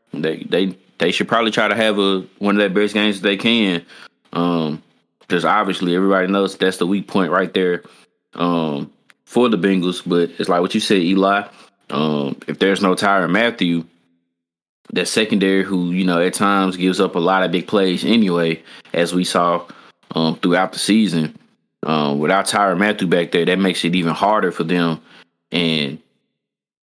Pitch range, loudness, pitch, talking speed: 85-100 Hz, -18 LUFS, 90 Hz, 180 wpm